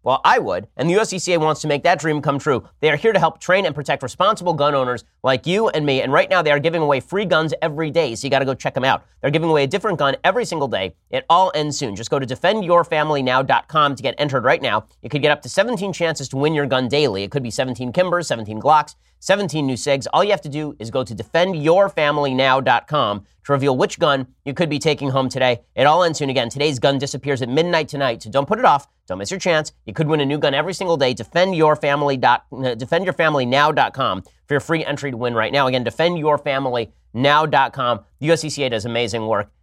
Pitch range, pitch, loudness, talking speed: 130-165 Hz, 145 Hz, -19 LUFS, 240 wpm